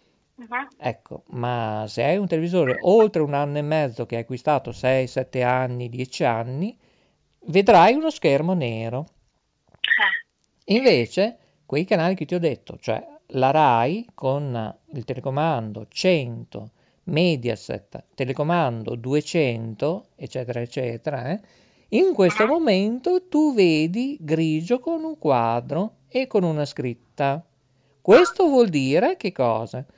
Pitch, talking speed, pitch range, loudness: 150 Hz, 120 wpm, 125-195 Hz, -22 LUFS